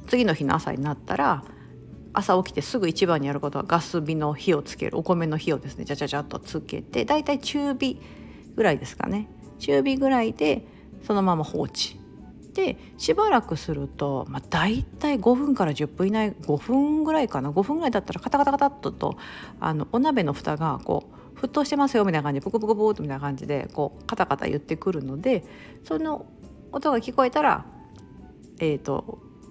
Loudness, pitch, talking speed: -25 LUFS, 190 Hz, 375 characters per minute